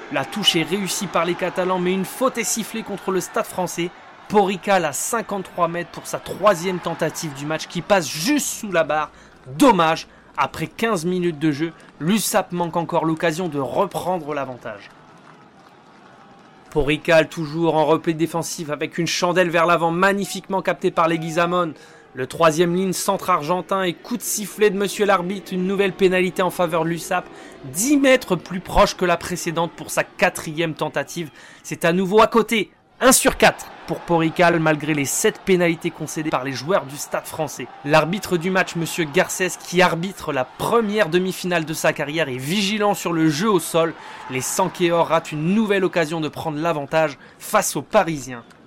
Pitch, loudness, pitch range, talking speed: 175 Hz, -20 LUFS, 160-195 Hz, 175 wpm